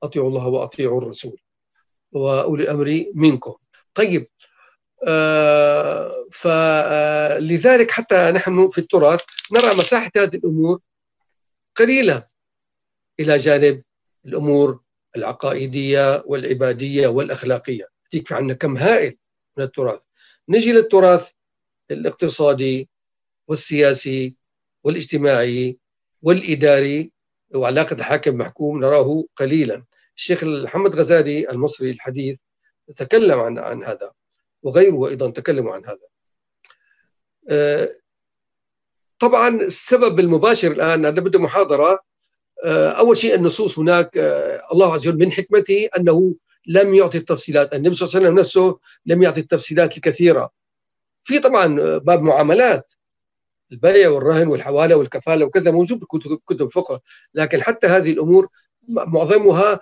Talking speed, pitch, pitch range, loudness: 100 wpm, 165 Hz, 145-195 Hz, -17 LUFS